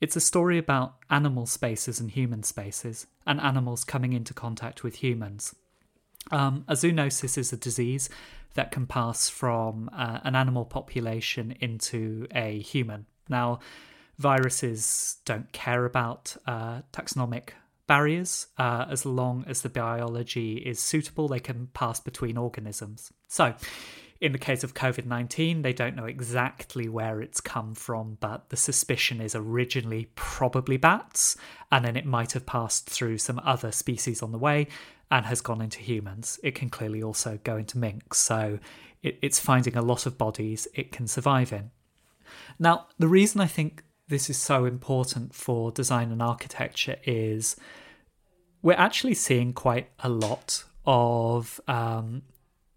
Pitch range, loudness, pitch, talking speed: 115-135 Hz, -27 LUFS, 125 Hz, 150 wpm